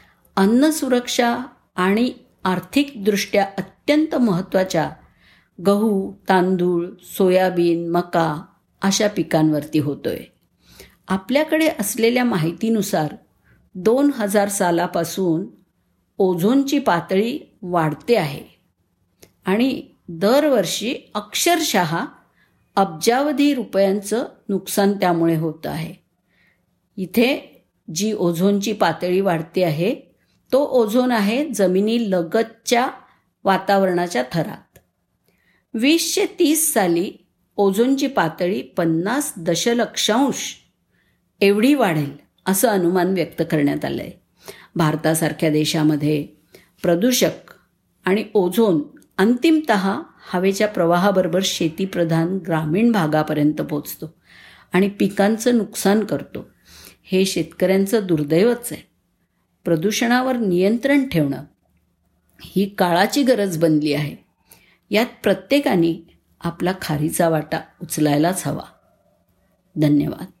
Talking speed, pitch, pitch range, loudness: 80 wpm, 190 Hz, 170-230 Hz, -19 LUFS